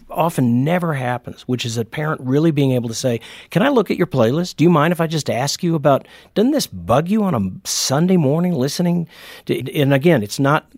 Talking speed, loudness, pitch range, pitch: 230 wpm, -18 LUFS, 125-170 Hz, 145 Hz